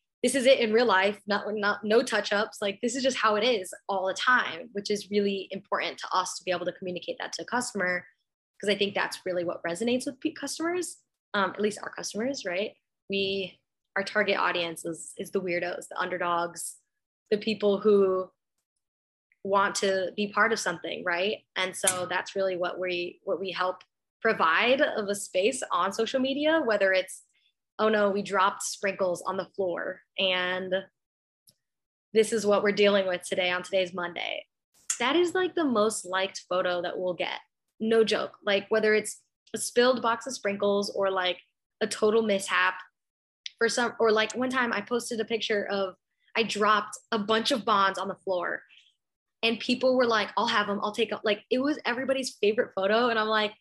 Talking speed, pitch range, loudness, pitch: 195 wpm, 185-225 Hz, -27 LUFS, 205 Hz